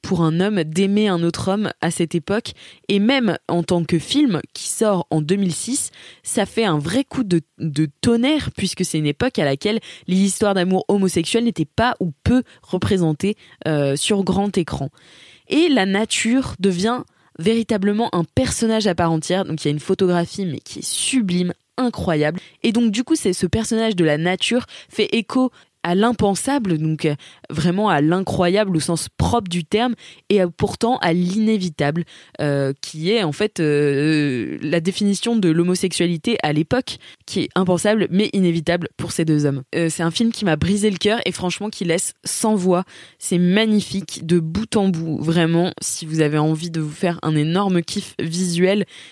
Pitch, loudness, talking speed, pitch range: 180 Hz, -20 LUFS, 185 wpm, 165-210 Hz